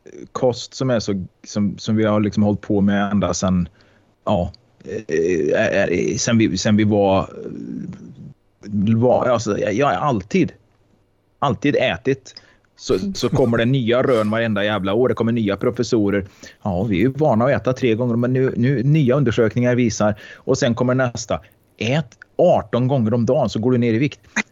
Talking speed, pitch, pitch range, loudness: 175 wpm, 115 Hz, 105-125 Hz, -19 LUFS